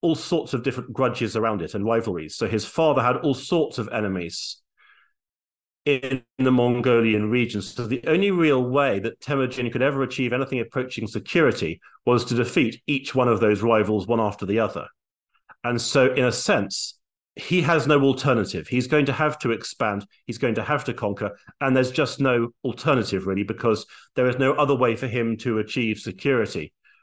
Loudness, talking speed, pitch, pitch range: -23 LUFS, 185 wpm, 125 Hz, 115-135 Hz